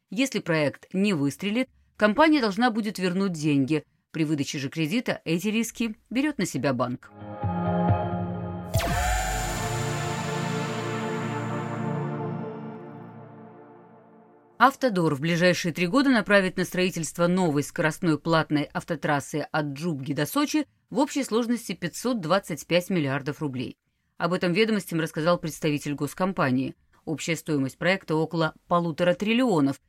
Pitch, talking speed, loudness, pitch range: 170 Hz, 105 wpm, -26 LUFS, 145-200 Hz